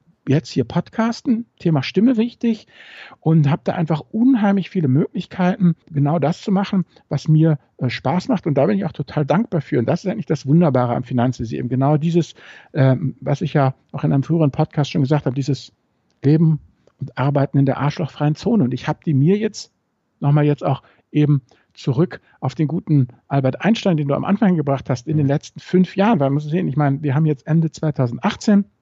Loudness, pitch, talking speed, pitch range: -19 LUFS, 150 Hz, 205 wpm, 140-180 Hz